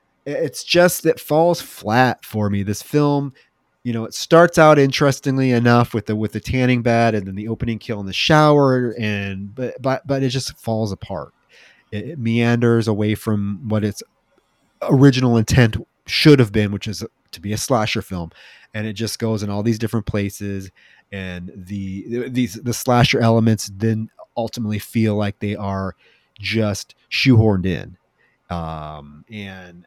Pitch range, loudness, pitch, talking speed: 100-125 Hz, -18 LUFS, 115 Hz, 170 wpm